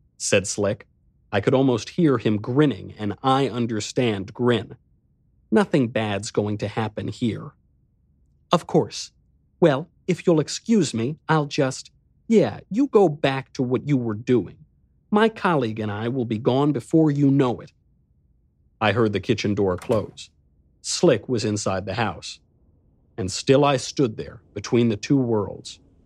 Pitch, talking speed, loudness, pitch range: 120 Hz, 155 wpm, -22 LUFS, 105-140 Hz